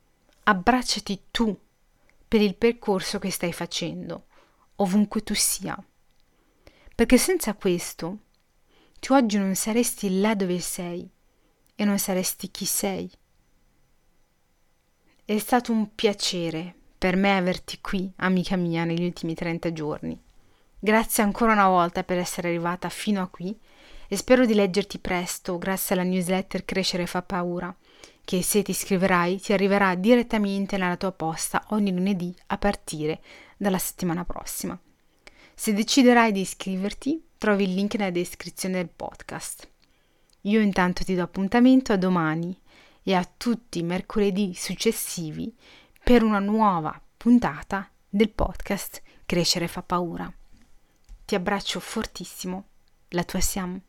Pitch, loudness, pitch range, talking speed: 195 Hz, -25 LUFS, 180-210 Hz, 130 wpm